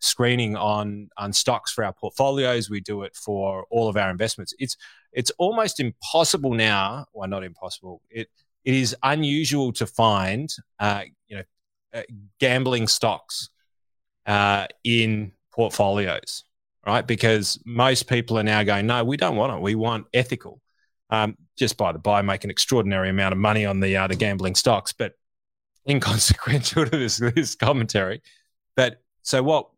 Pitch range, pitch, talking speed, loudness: 100-125 Hz, 110 Hz, 160 wpm, -23 LUFS